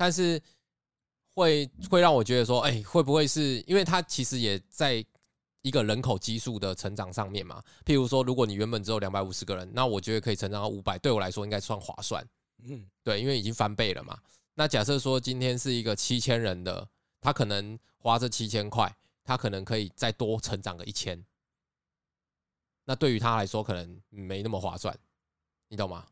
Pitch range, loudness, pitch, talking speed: 100-130 Hz, -29 LUFS, 110 Hz, 295 characters per minute